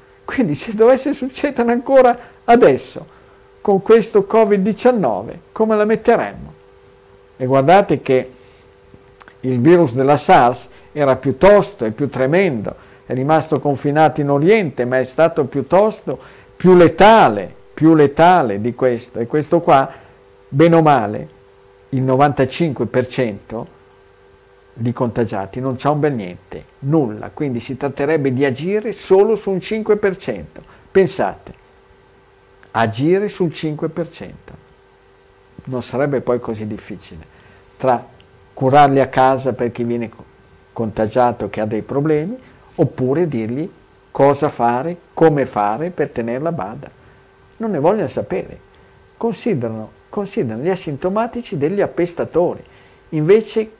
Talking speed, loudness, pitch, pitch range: 115 wpm, -16 LUFS, 135 Hz, 110-180 Hz